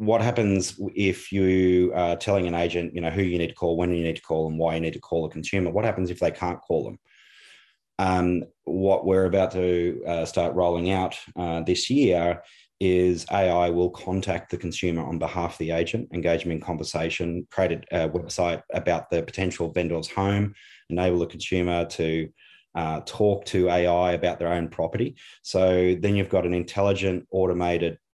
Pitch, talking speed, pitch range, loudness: 90 Hz, 190 wpm, 85-95 Hz, -25 LUFS